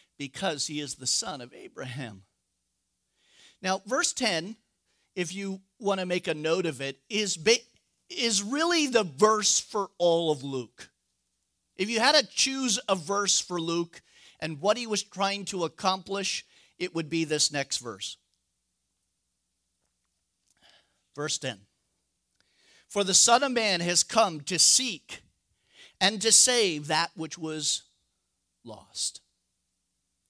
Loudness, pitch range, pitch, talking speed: -26 LUFS, 145-205 Hz, 175 Hz, 135 wpm